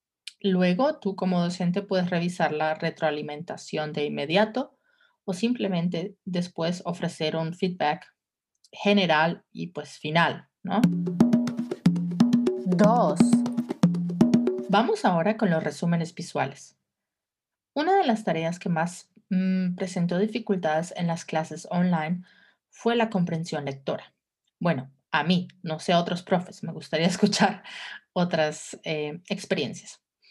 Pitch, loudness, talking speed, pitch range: 180 Hz, -26 LUFS, 115 wpm, 165-205 Hz